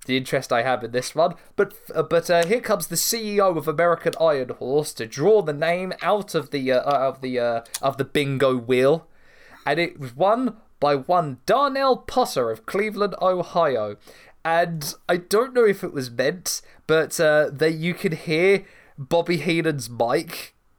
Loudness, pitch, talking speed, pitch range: -22 LUFS, 160 Hz, 180 wpm, 135-185 Hz